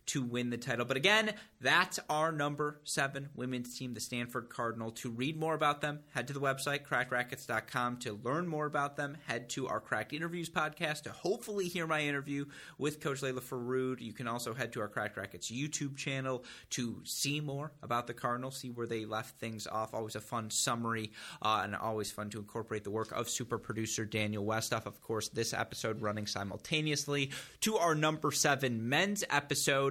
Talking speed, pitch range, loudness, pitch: 195 wpm, 115-145 Hz, -35 LUFS, 125 Hz